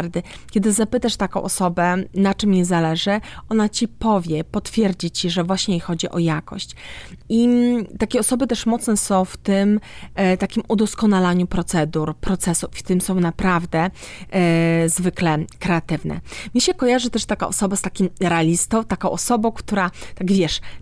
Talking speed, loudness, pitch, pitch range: 150 wpm, -20 LUFS, 190 Hz, 175-215 Hz